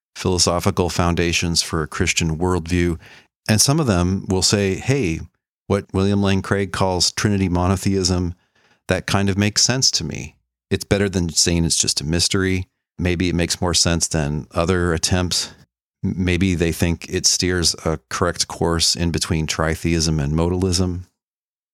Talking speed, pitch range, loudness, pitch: 155 wpm, 80-95 Hz, -19 LUFS, 90 Hz